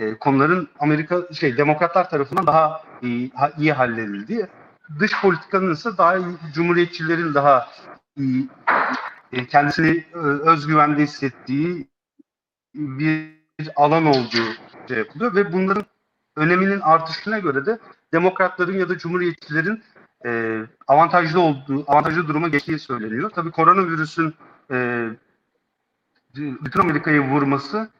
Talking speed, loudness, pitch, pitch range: 110 wpm, -20 LUFS, 155 Hz, 140-180 Hz